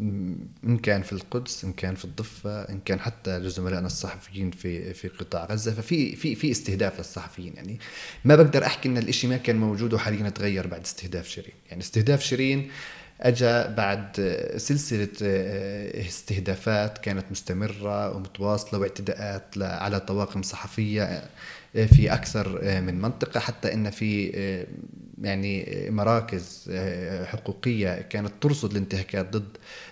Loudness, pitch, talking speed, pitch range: -26 LUFS, 100 Hz, 130 wpm, 95-110 Hz